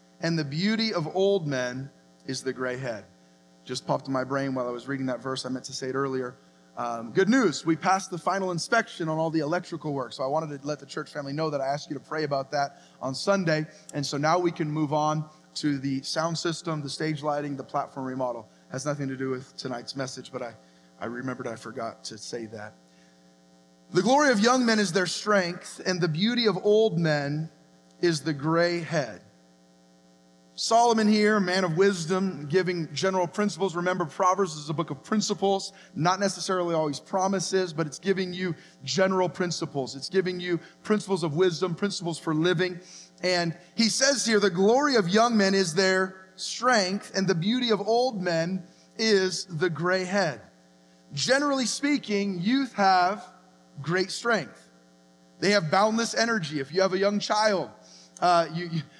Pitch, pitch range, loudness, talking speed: 170 Hz, 135-190 Hz, -26 LUFS, 190 wpm